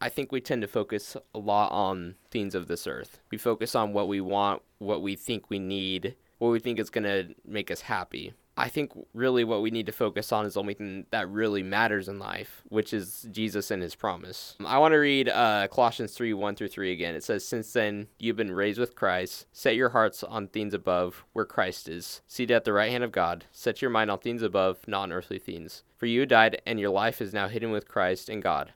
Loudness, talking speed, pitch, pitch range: -28 LUFS, 235 wpm, 105 Hz, 100-115 Hz